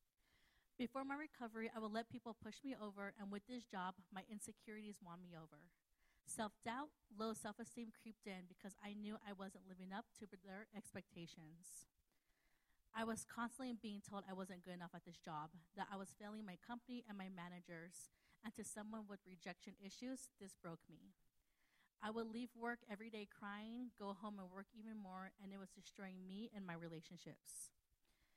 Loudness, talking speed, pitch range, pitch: -53 LUFS, 185 wpm, 185-225 Hz, 200 Hz